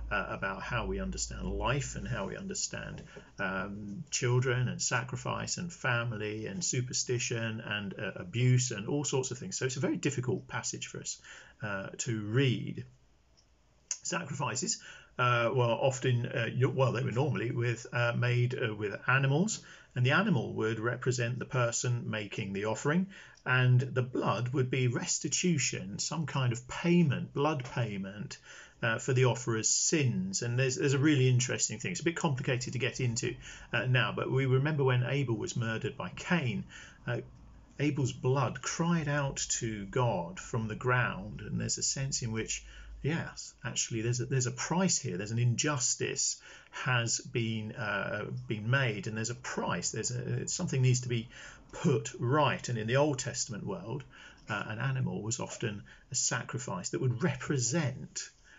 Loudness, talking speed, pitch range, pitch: -32 LUFS, 170 wpm, 115-140 Hz, 125 Hz